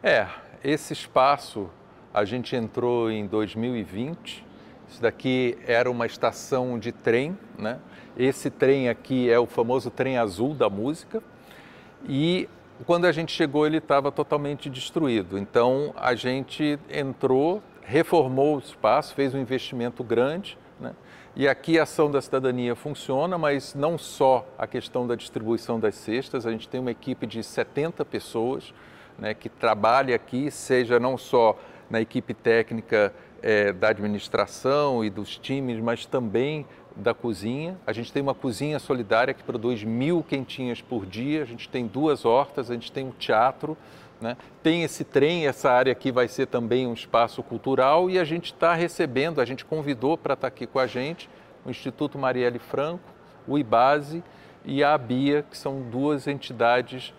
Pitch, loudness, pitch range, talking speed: 130 Hz, -25 LUFS, 120-145 Hz, 160 wpm